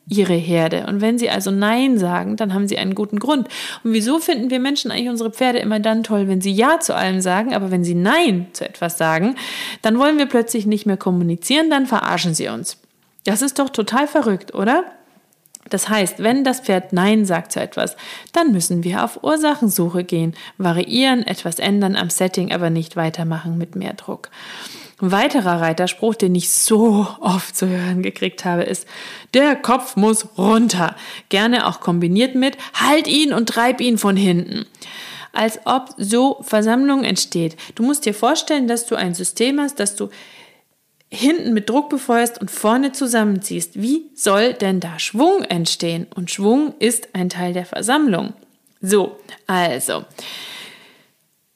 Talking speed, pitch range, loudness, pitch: 170 wpm, 185-250 Hz, -18 LUFS, 215 Hz